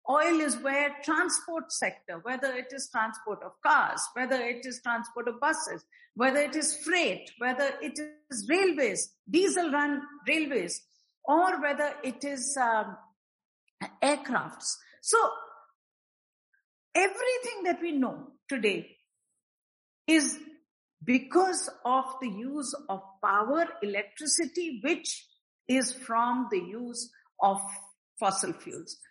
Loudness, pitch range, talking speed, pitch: -29 LUFS, 240-315 Hz, 115 wpm, 280 Hz